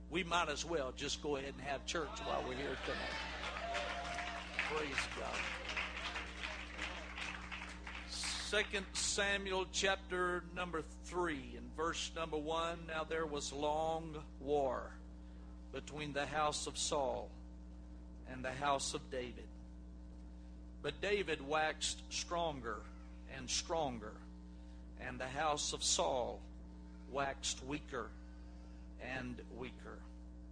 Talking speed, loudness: 110 wpm, -40 LUFS